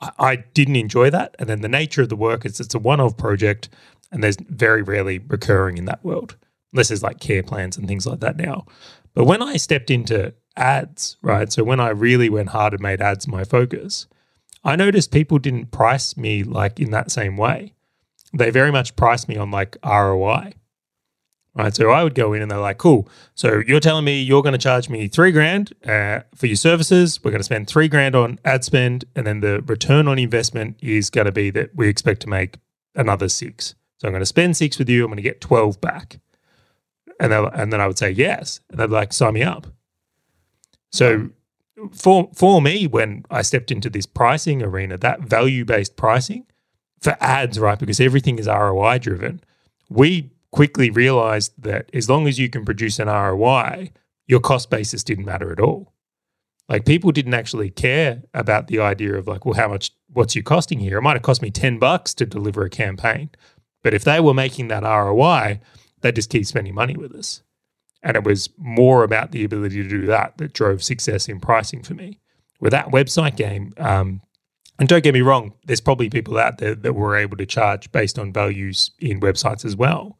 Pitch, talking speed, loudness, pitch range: 120 Hz, 205 wpm, -18 LUFS, 105-140 Hz